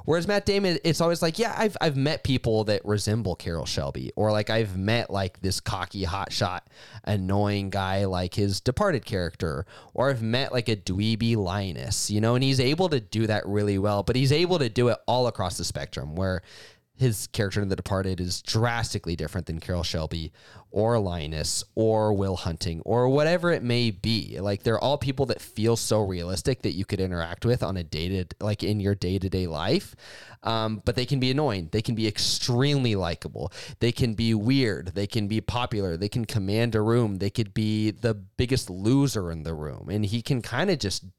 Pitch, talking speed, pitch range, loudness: 110 Hz, 200 wpm, 95-120 Hz, -26 LUFS